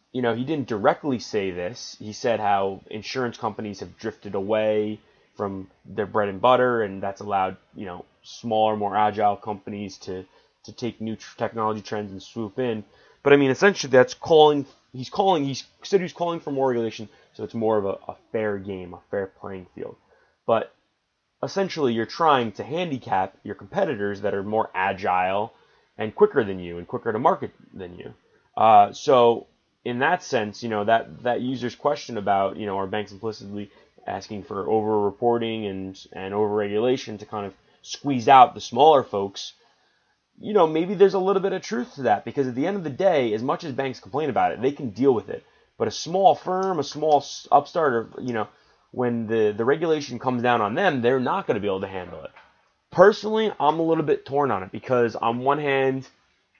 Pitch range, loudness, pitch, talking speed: 105-140 Hz, -23 LUFS, 115 Hz, 200 wpm